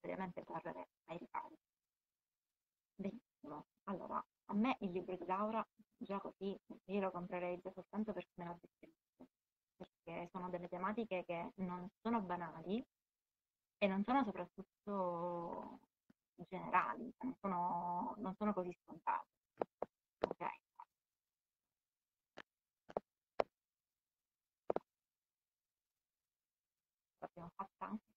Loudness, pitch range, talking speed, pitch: -44 LUFS, 180-220 Hz, 90 wpm, 195 Hz